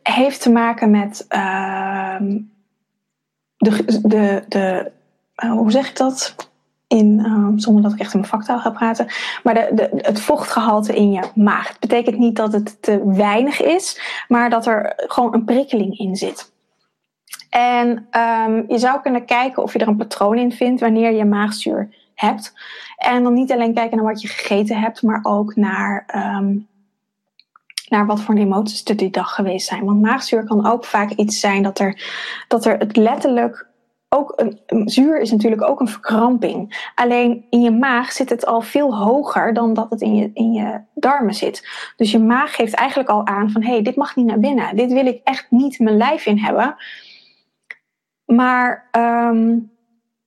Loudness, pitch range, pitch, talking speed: -17 LUFS, 210-245 Hz, 225 Hz, 185 wpm